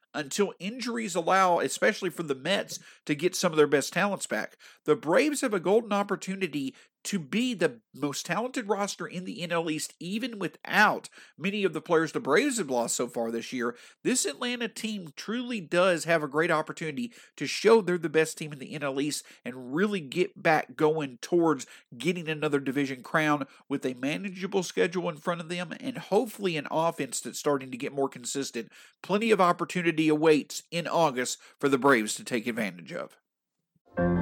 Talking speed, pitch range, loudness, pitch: 185 wpm, 145-195 Hz, -28 LUFS, 170 Hz